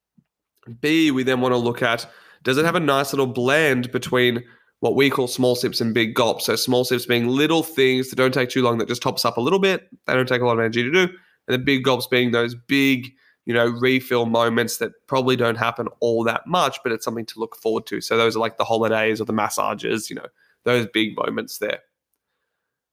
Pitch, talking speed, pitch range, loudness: 125 Hz, 235 wpm, 115-130 Hz, -21 LUFS